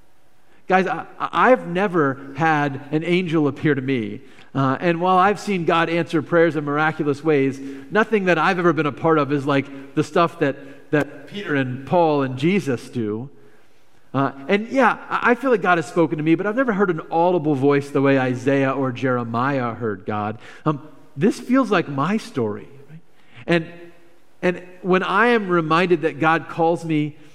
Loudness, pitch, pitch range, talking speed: -20 LUFS, 155 Hz, 140-180 Hz, 180 wpm